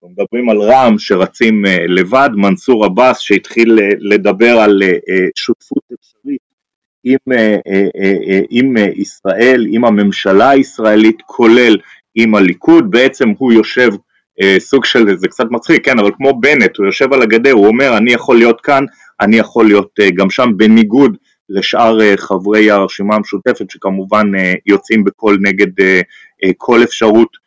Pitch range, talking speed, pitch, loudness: 100-120 Hz, 130 wpm, 110 Hz, -10 LUFS